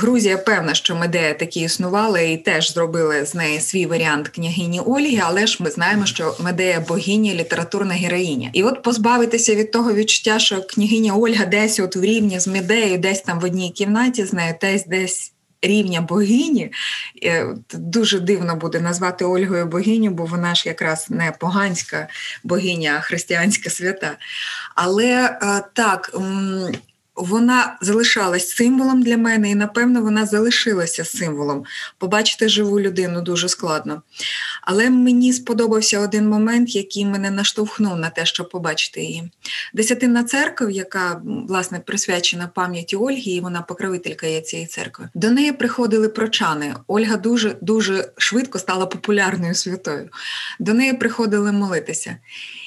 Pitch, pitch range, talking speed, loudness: 195 Hz, 175-220 Hz, 140 wpm, -18 LUFS